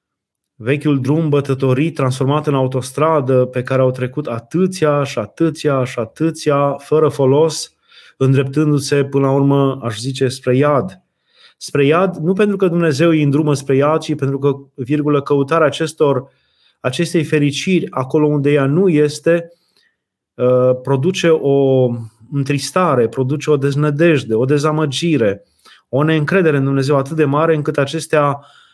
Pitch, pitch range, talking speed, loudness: 145 Hz, 135-155 Hz, 135 wpm, -15 LUFS